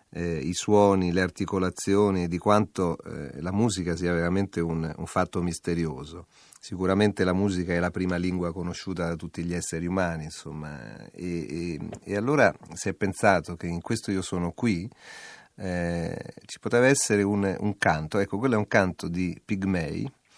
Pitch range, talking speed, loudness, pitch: 85-100 Hz, 170 wpm, -27 LUFS, 90 Hz